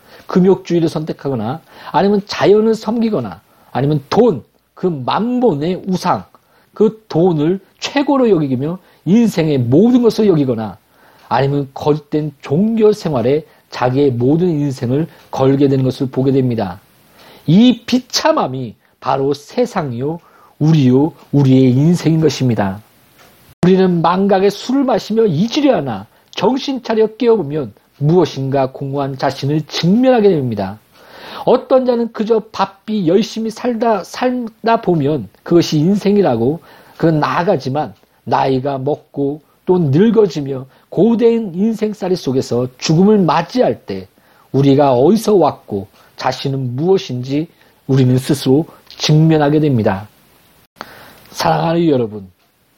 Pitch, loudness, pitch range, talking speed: 160 Hz, -15 LUFS, 135-205 Hz, 270 characters per minute